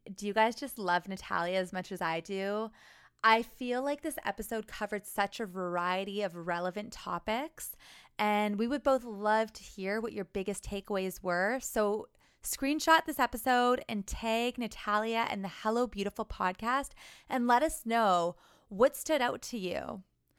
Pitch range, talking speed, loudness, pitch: 195-245 Hz, 165 wpm, -32 LUFS, 215 Hz